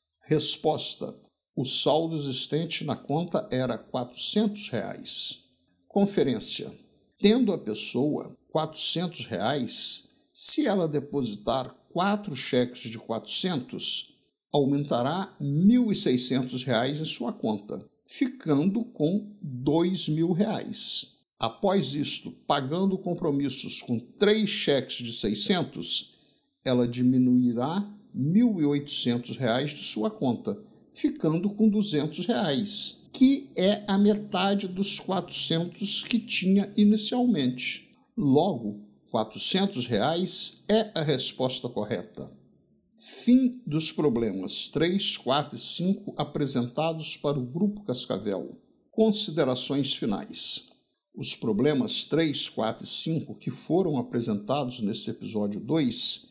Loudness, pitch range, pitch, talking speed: -21 LUFS, 135-205 Hz, 160 Hz, 105 wpm